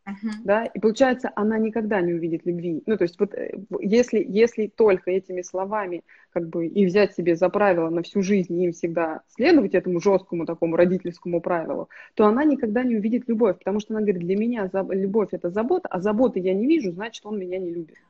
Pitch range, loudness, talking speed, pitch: 180-220 Hz, -23 LUFS, 205 wpm, 195 Hz